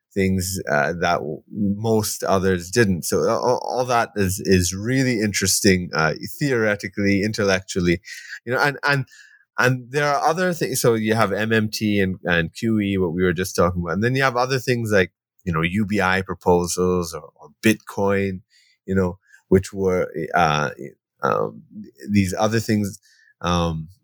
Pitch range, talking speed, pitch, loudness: 95-110 Hz, 155 wpm, 100 Hz, -21 LUFS